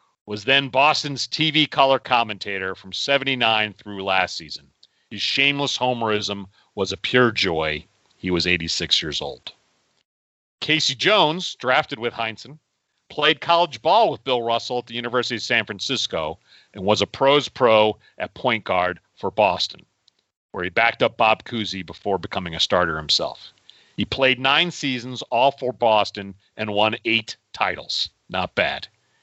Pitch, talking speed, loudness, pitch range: 115 Hz, 150 wpm, -21 LUFS, 100-135 Hz